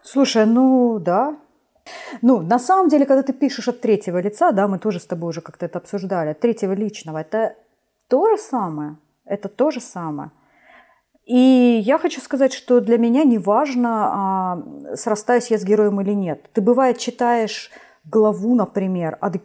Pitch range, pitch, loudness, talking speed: 195-260 Hz, 230 Hz, -19 LUFS, 165 wpm